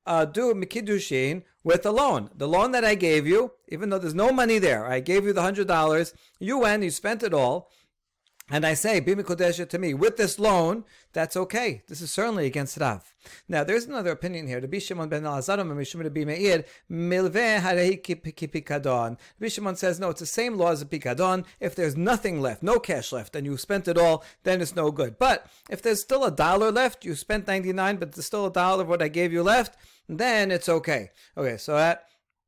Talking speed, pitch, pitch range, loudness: 190 wpm, 180 Hz, 160-205 Hz, -25 LUFS